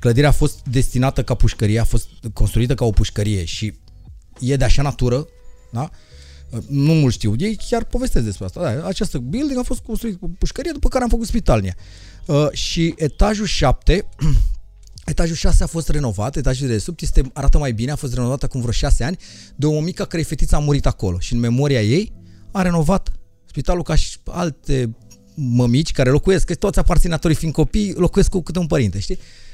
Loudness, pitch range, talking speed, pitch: -20 LUFS, 110-170 Hz, 190 wpm, 135 Hz